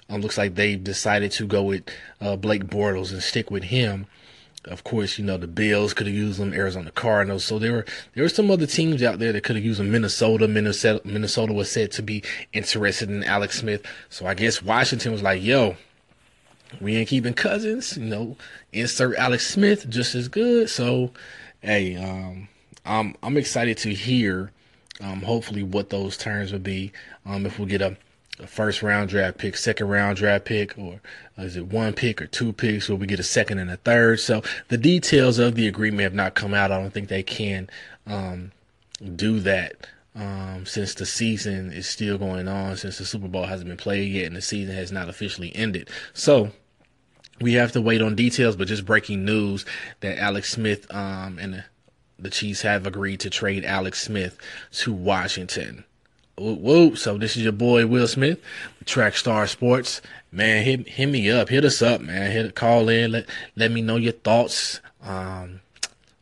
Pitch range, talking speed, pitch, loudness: 100-115 Hz, 195 wpm, 105 Hz, -23 LUFS